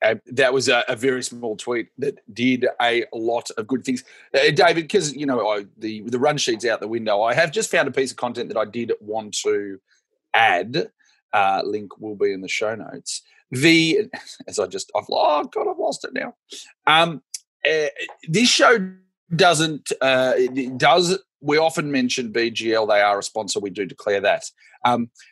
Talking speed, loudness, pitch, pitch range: 195 wpm, -20 LUFS, 135 Hz, 120-185 Hz